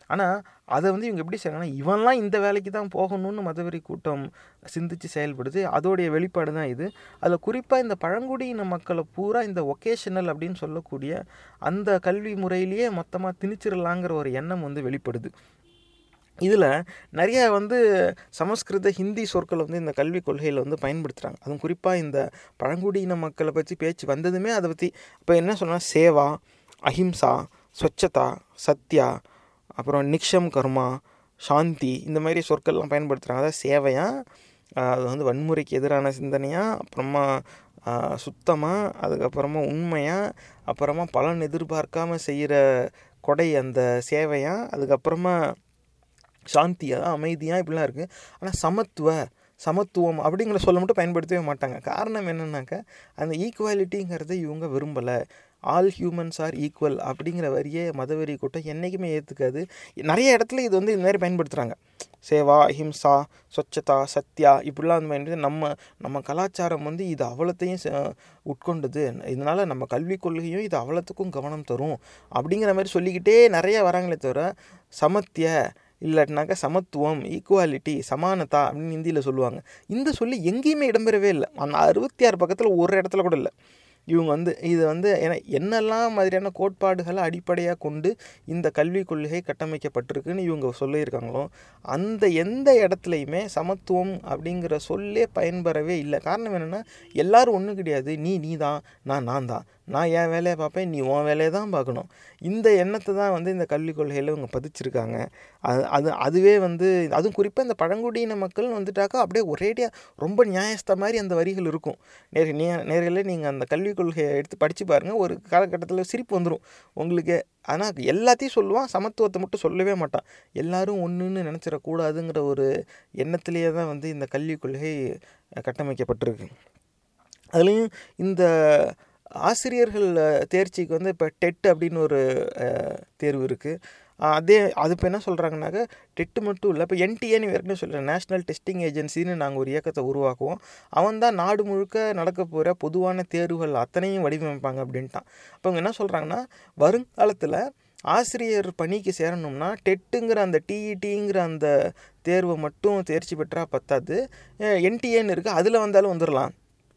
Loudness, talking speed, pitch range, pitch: -24 LUFS, 130 wpm, 150-195 Hz, 170 Hz